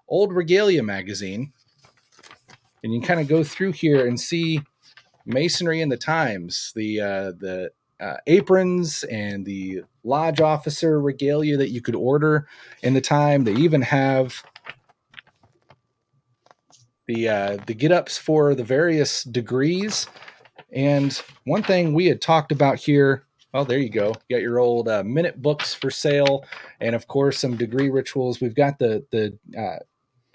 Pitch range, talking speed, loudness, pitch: 120-155 Hz, 155 wpm, -21 LUFS, 135 Hz